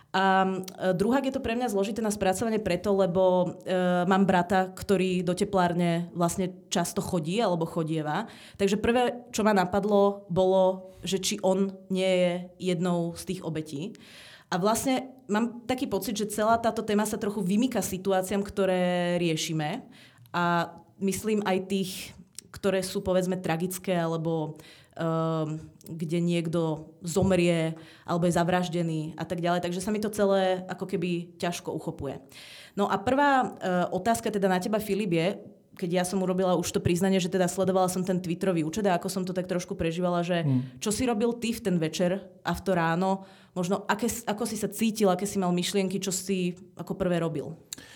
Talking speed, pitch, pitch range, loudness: 175 wpm, 185 Hz, 175-200 Hz, -27 LUFS